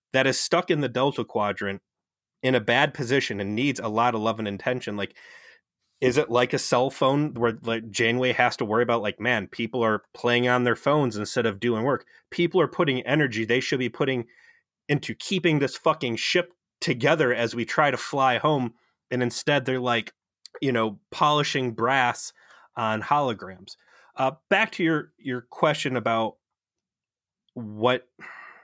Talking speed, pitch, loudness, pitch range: 175 wpm, 125 Hz, -24 LUFS, 115-145 Hz